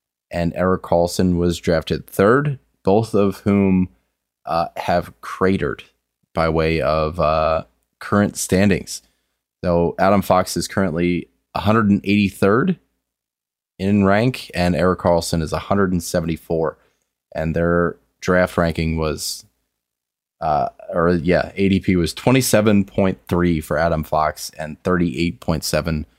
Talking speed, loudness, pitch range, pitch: 110 wpm, -19 LUFS, 85-95 Hz, 90 Hz